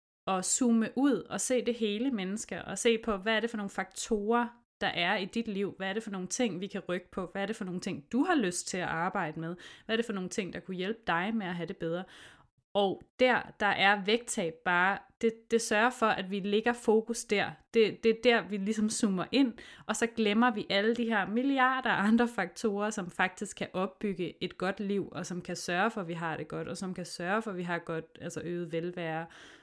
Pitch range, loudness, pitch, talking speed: 180-225 Hz, -31 LUFS, 200 Hz, 245 wpm